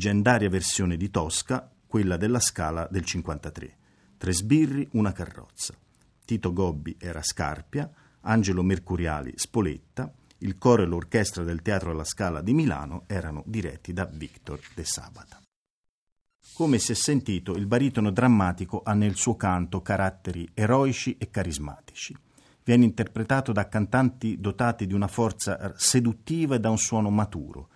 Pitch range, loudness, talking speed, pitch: 90-115 Hz, -26 LUFS, 140 wpm, 100 Hz